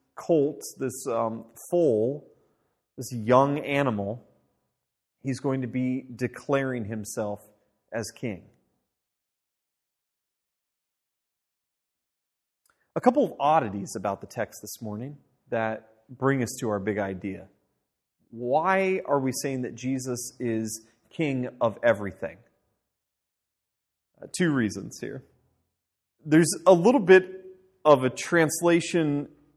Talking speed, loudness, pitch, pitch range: 105 wpm, -26 LUFS, 125 Hz, 110-145 Hz